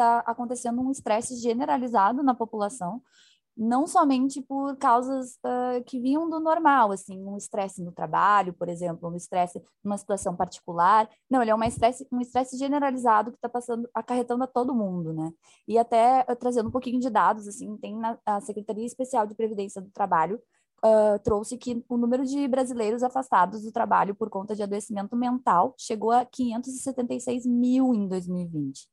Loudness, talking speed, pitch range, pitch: -26 LUFS, 170 wpm, 205-250 Hz, 235 Hz